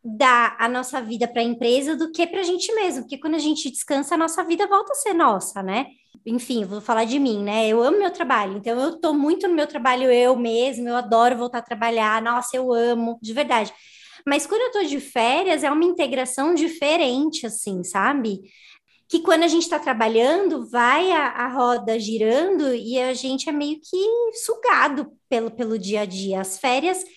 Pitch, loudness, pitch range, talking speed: 260 Hz, -21 LUFS, 230-320 Hz, 205 wpm